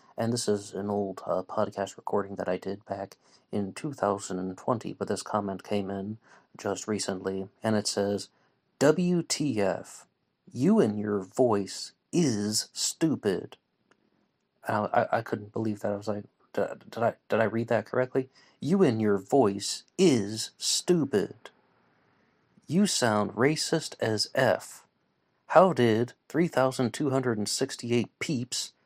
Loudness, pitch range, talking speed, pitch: -28 LUFS, 100-130 Hz, 130 wpm, 105 Hz